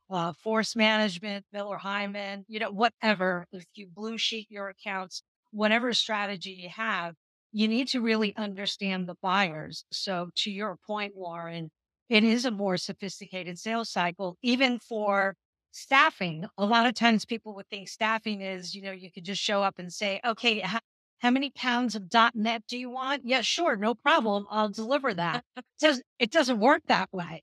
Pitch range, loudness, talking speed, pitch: 190-230 Hz, -28 LUFS, 180 wpm, 210 Hz